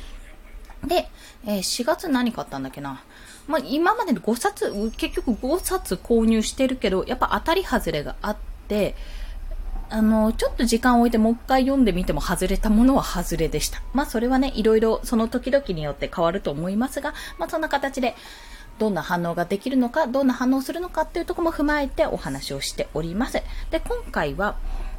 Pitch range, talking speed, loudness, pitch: 185-280 Hz, 365 characters per minute, -23 LUFS, 235 Hz